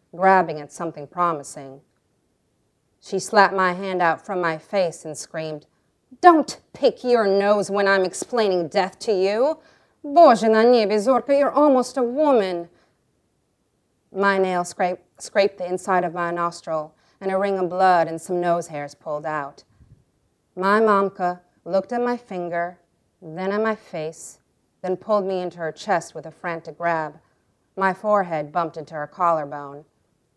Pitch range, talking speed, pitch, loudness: 160-200 Hz, 150 wpm, 180 Hz, -21 LUFS